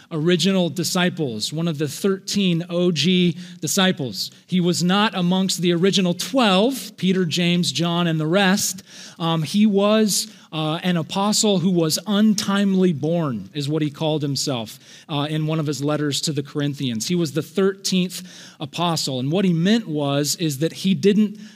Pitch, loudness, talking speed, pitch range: 175 Hz, -20 LUFS, 165 wpm, 155-195 Hz